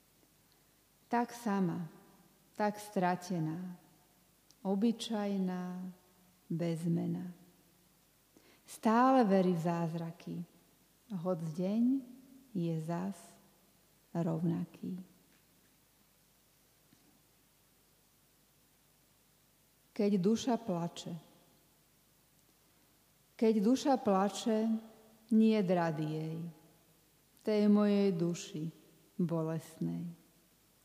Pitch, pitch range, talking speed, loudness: 180 Hz, 170-210 Hz, 55 wpm, -34 LUFS